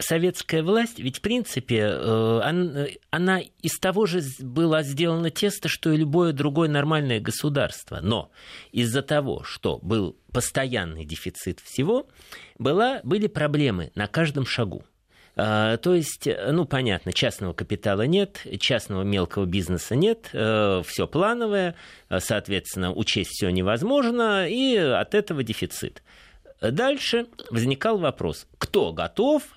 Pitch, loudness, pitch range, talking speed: 145 Hz, -24 LUFS, 105-180 Hz, 120 wpm